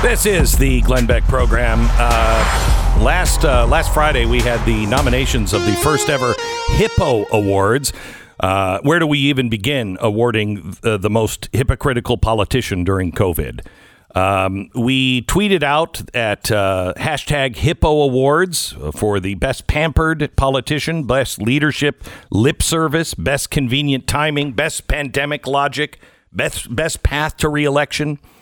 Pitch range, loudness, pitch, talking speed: 110-145 Hz, -17 LUFS, 130 Hz, 135 wpm